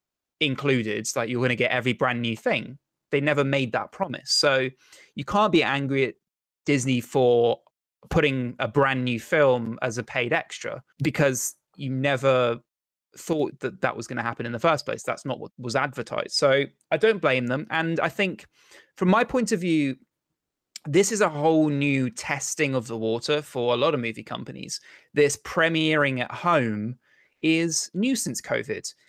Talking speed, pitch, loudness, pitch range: 180 wpm, 135 Hz, -24 LUFS, 125-160 Hz